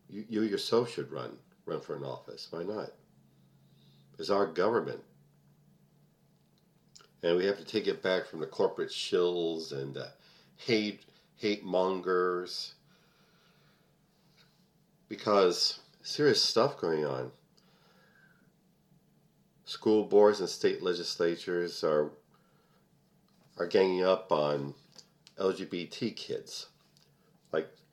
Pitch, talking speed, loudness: 110 Hz, 105 wpm, -31 LUFS